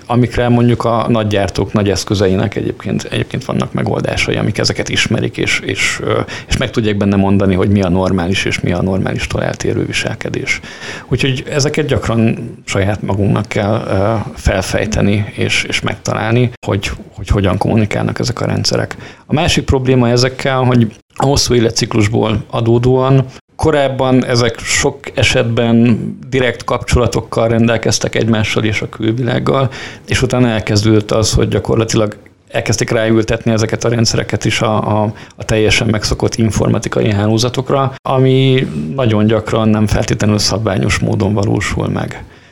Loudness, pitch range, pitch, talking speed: -14 LUFS, 105-125 Hz, 115 Hz, 135 wpm